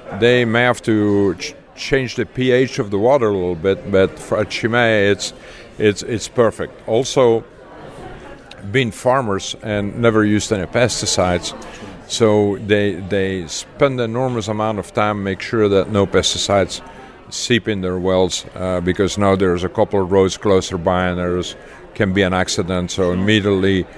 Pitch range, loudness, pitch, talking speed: 95-110 Hz, -17 LUFS, 100 Hz, 165 wpm